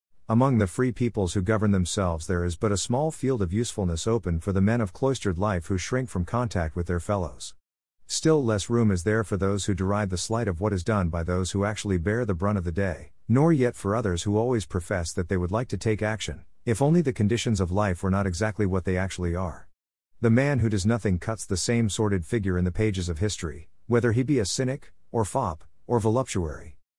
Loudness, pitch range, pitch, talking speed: -26 LUFS, 90-115 Hz, 105 Hz, 235 wpm